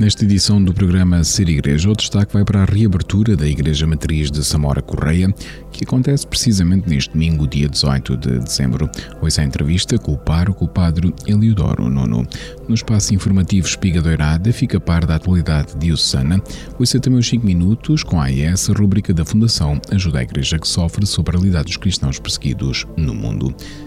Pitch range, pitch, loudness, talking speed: 75-105 Hz, 90 Hz, -16 LUFS, 185 wpm